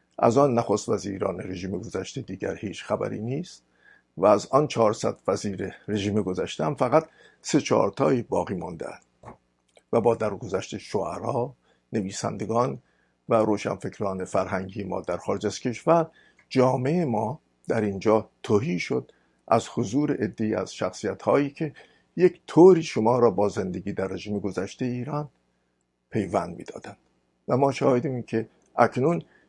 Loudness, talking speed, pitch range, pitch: -25 LUFS, 135 wpm, 95-125 Hz, 105 Hz